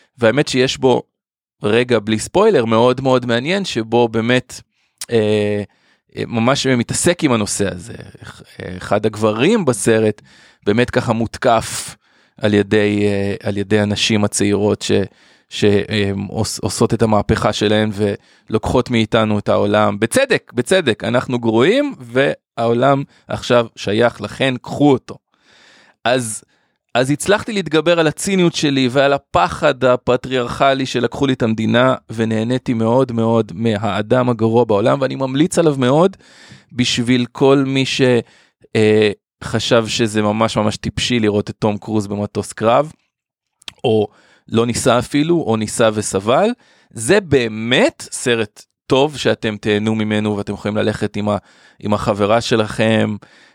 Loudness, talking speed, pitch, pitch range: -16 LUFS, 120 wpm, 115 Hz, 105-130 Hz